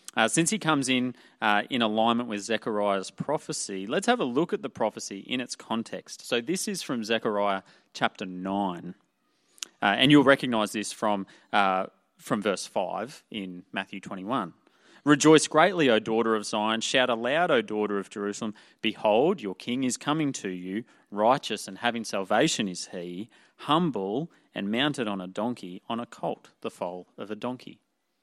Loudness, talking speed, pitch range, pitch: -27 LUFS, 170 wpm, 100-125 Hz, 110 Hz